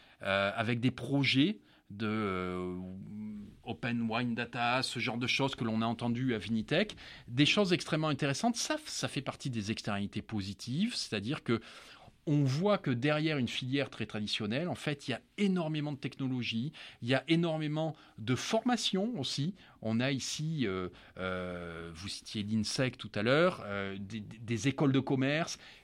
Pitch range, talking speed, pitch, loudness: 110-145 Hz, 165 wpm, 125 Hz, -33 LUFS